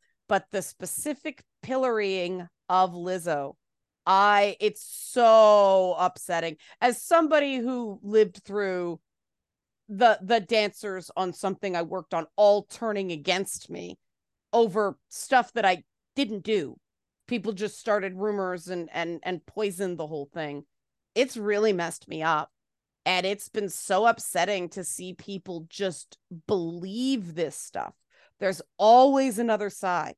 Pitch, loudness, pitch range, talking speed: 195 Hz, -26 LUFS, 175-215 Hz, 130 wpm